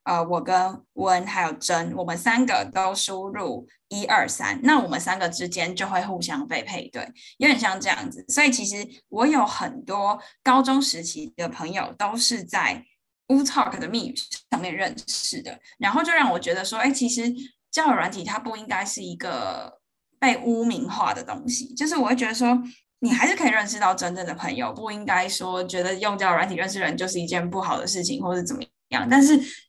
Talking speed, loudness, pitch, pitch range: 300 characters per minute, -23 LUFS, 235 Hz, 190-265 Hz